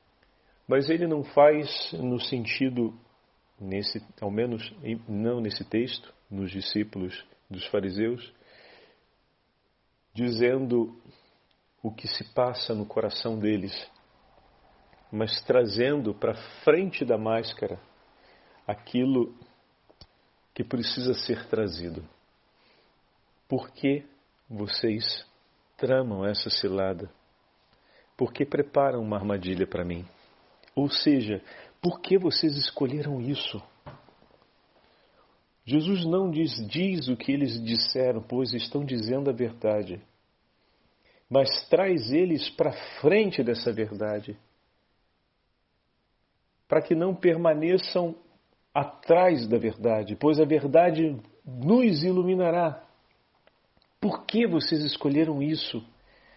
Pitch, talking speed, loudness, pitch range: 120 Hz, 100 wpm, -27 LUFS, 105-150 Hz